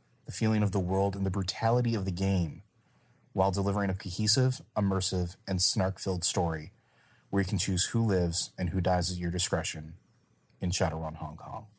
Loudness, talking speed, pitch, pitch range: -30 LUFS, 180 wpm, 95 Hz, 90-105 Hz